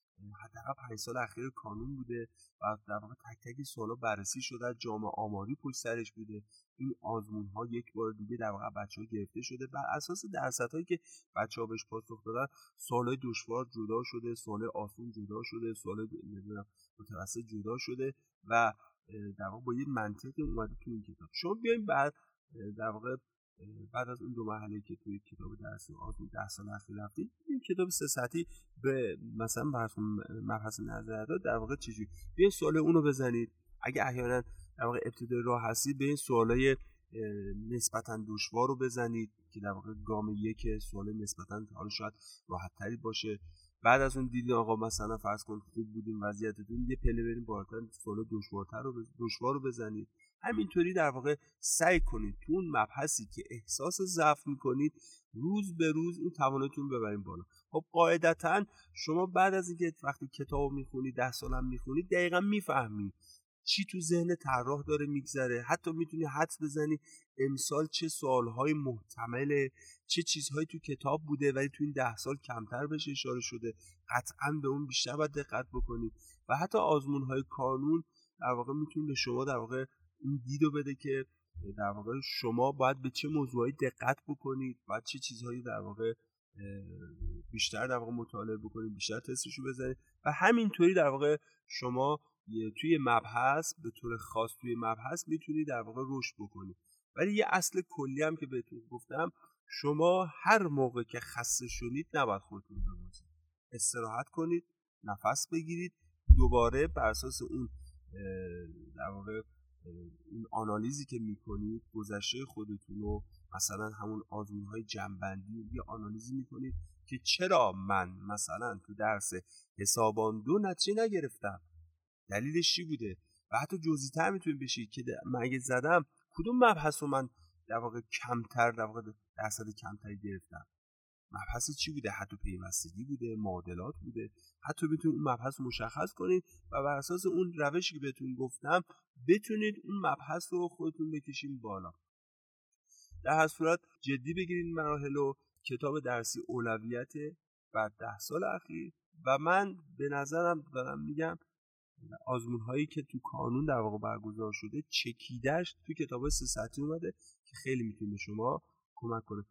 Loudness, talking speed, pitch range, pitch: -35 LUFS, 155 wpm, 105-145 Hz, 120 Hz